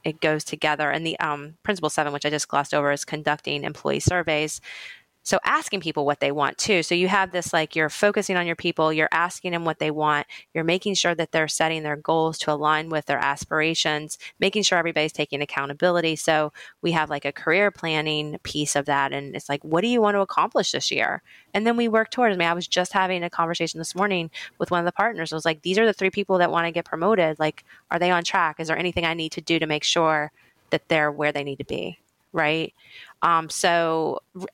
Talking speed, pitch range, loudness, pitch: 240 wpm, 150-175 Hz, -23 LUFS, 160 Hz